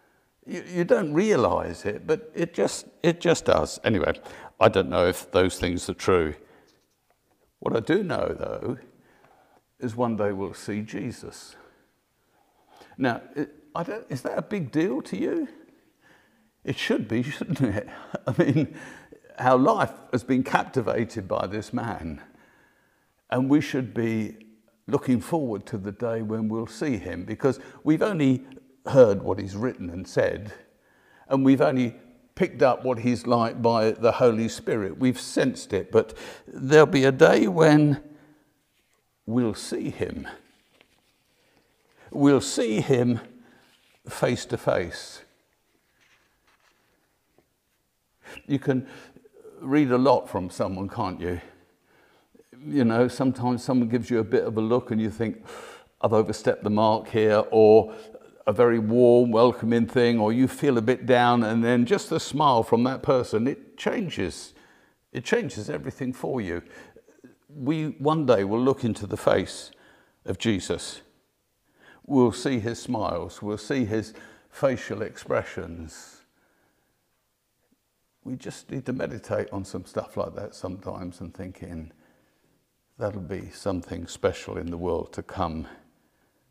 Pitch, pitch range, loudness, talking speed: 120 Hz, 105-135 Hz, -24 LUFS, 145 wpm